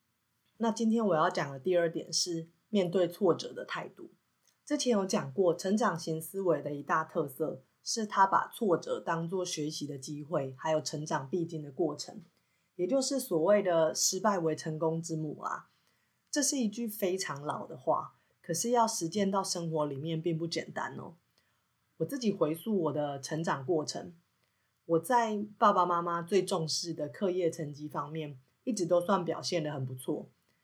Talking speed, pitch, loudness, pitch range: 255 characters per minute, 170 Hz, -32 LUFS, 155-200 Hz